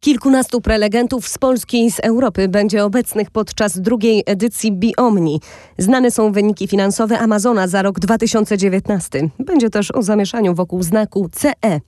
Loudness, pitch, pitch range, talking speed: -16 LUFS, 215 Hz, 200-235 Hz, 140 wpm